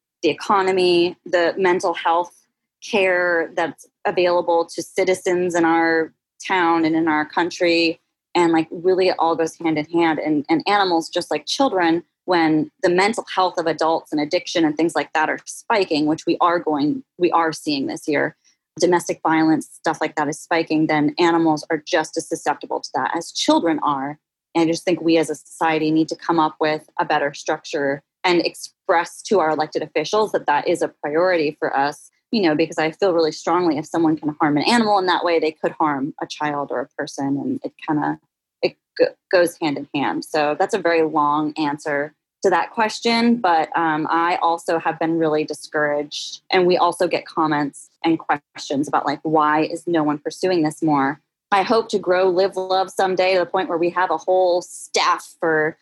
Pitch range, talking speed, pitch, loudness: 155-180 Hz, 200 wpm, 165 Hz, -20 LUFS